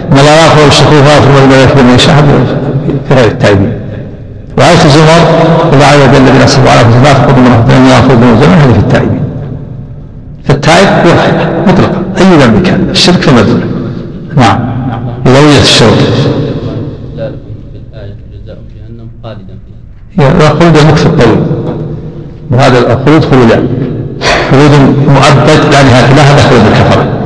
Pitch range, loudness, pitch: 120-150 Hz, -4 LUFS, 135 Hz